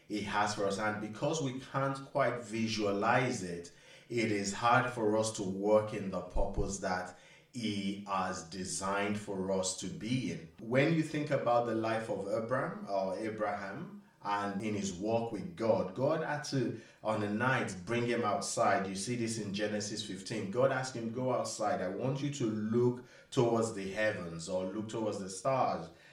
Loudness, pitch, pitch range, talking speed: -34 LUFS, 110 Hz, 100-120 Hz, 180 wpm